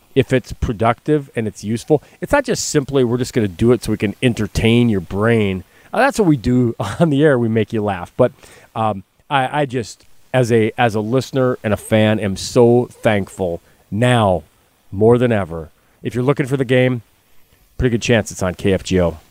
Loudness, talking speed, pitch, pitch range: -17 LUFS, 200 wpm, 115 Hz, 100-130 Hz